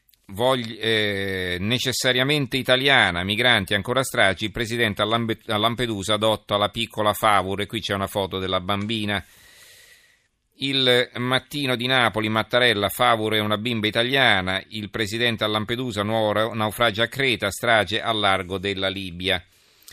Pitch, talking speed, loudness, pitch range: 110 Hz, 130 wpm, -21 LUFS, 100-125 Hz